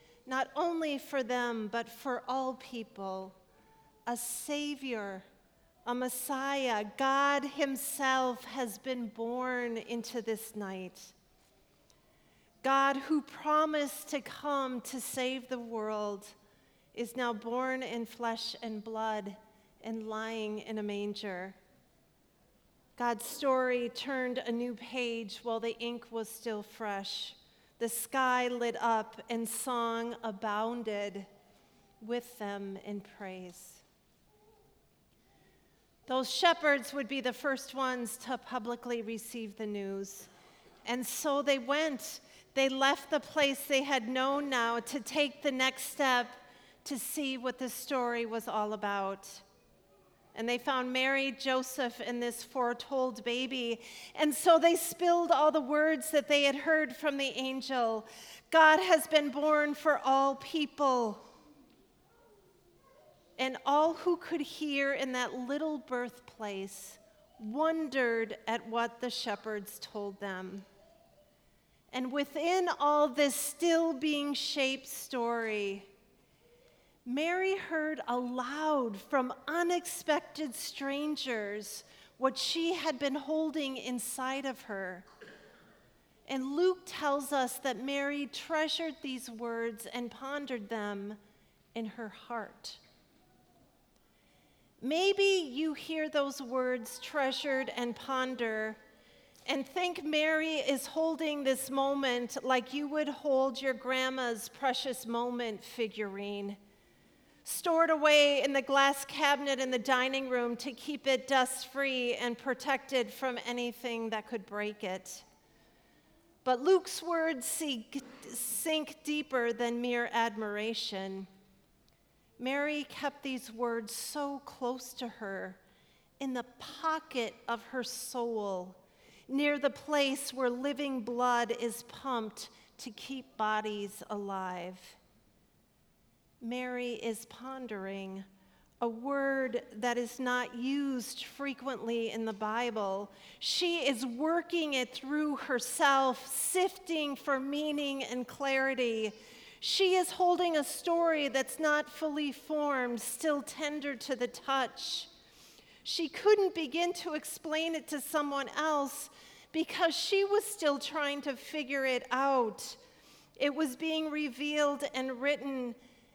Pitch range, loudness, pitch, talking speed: 230-285 Hz, -33 LUFS, 255 Hz, 120 wpm